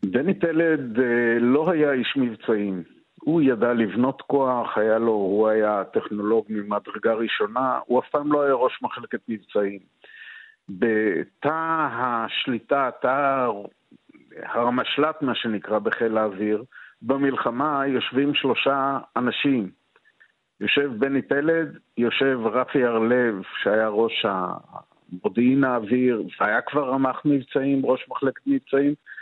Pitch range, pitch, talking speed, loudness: 110-140 Hz, 125 Hz, 110 wpm, -23 LUFS